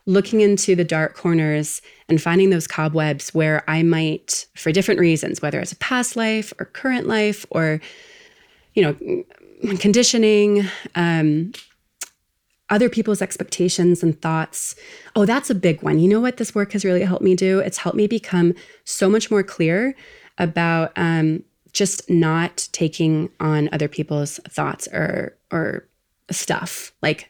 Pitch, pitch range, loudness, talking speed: 185 Hz, 165-210 Hz, -20 LUFS, 145 wpm